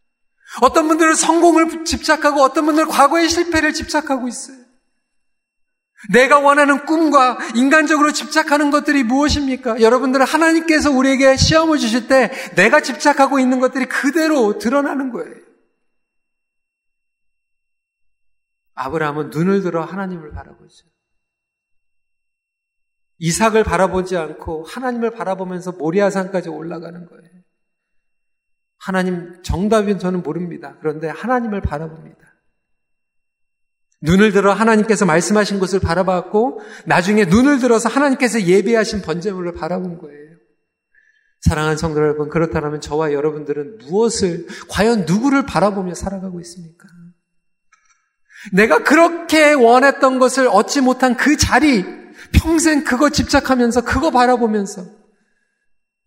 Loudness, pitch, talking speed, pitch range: -15 LUFS, 225 Hz, 305 characters per minute, 175-275 Hz